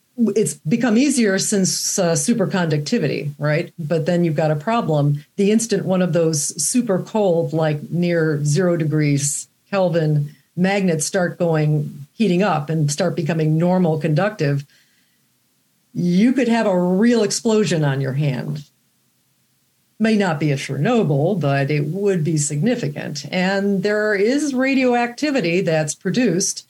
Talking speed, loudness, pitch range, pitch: 135 wpm, -19 LUFS, 155-205 Hz, 175 Hz